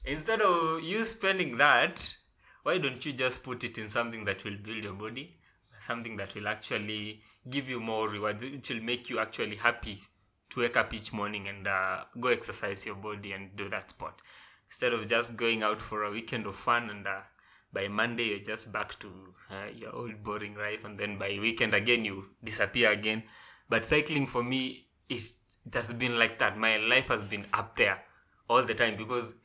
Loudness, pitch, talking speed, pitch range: -30 LUFS, 110 Hz, 200 wpm, 105-120 Hz